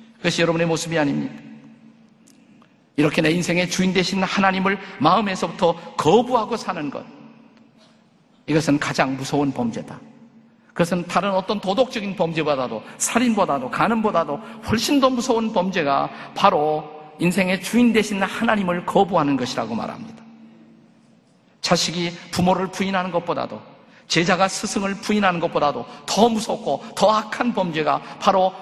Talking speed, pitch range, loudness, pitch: 320 characters per minute, 170-230 Hz, -21 LUFS, 190 Hz